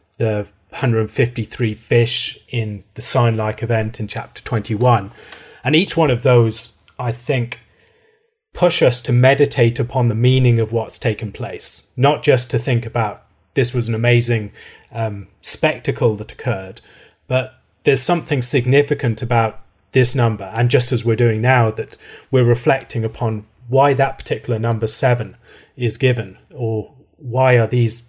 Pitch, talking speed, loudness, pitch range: 120 Hz, 145 wpm, -17 LUFS, 110-130 Hz